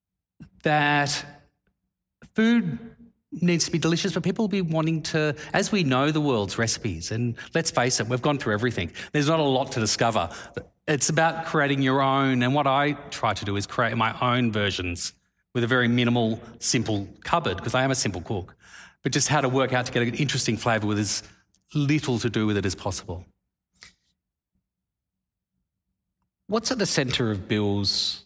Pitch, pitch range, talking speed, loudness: 125 Hz, 105-150 Hz, 185 wpm, -24 LUFS